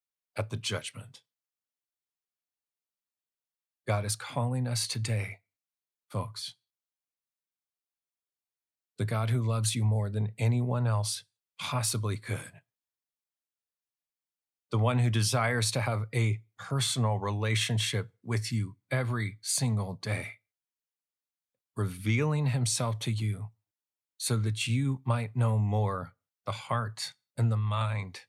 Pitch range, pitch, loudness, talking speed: 105-120 Hz, 110 Hz, -30 LUFS, 105 wpm